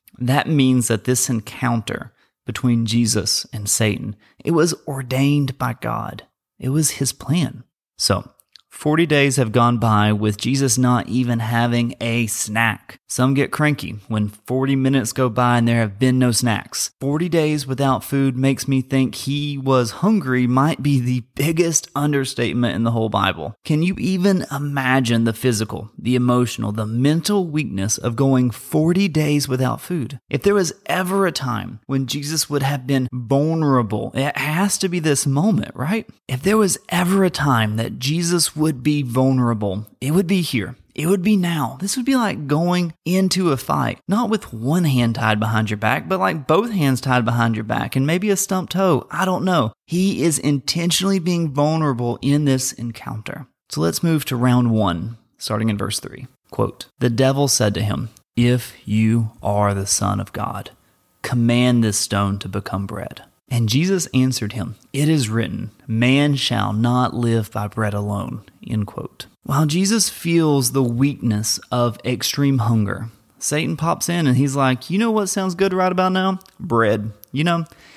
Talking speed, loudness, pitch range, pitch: 175 wpm, -19 LUFS, 115-155 Hz, 130 Hz